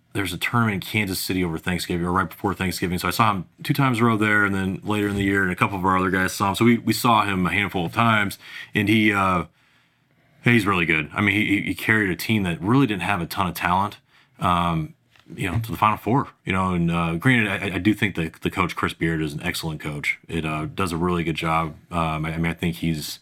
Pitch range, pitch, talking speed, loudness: 85-110 Hz, 95 Hz, 270 wpm, -22 LUFS